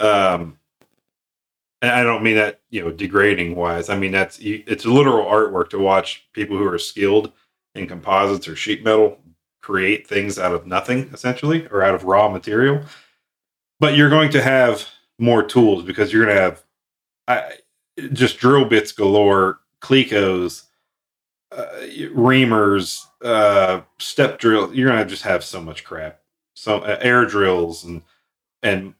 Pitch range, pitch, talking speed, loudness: 95-125 Hz, 105 Hz, 155 wpm, -17 LUFS